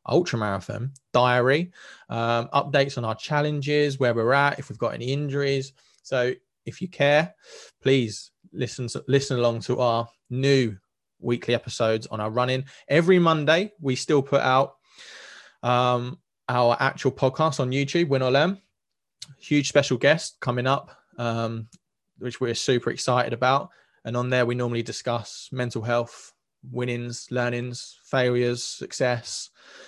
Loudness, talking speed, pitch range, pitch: -24 LUFS, 145 wpm, 120-140 Hz, 125 Hz